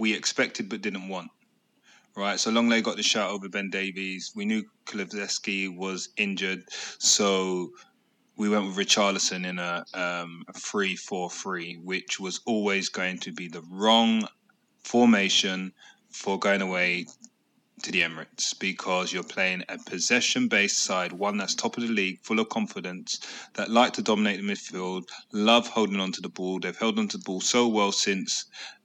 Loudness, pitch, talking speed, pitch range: -26 LUFS, 100 Hz, 170 wpm, 95-115 Hz